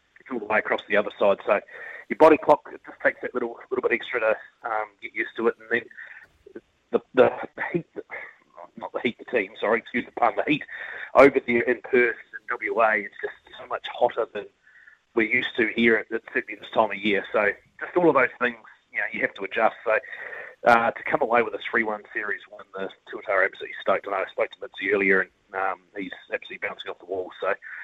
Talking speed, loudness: 230 wpm, -24 LUFS